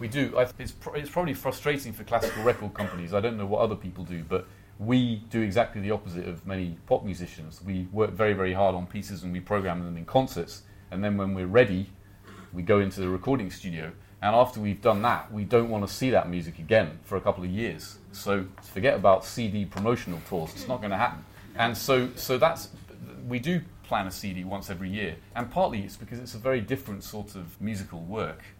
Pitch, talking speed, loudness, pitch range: 100 Hz, 215 wpm, -28 LUFS, 95-115 Hz